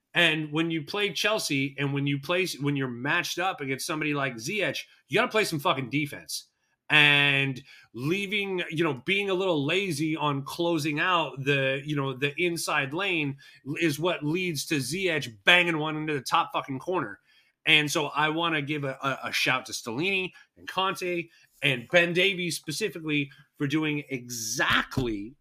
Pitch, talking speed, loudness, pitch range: 155 Hz, 170 wpm, -26 LUFS, 140-175 Hz